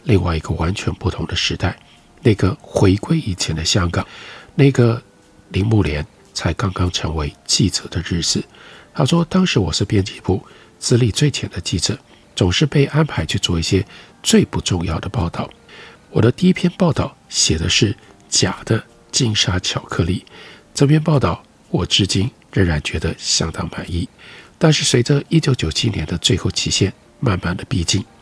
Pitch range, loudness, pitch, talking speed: 90-140 Hz, -18 LUFS, 105 Hz, 240 characters per minute